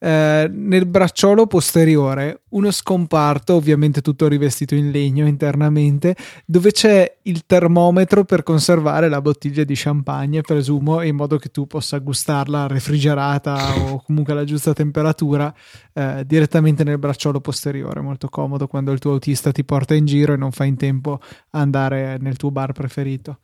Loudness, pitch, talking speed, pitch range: -17 LUFS, 150 Hz, 160 wpm, 140-160 Hz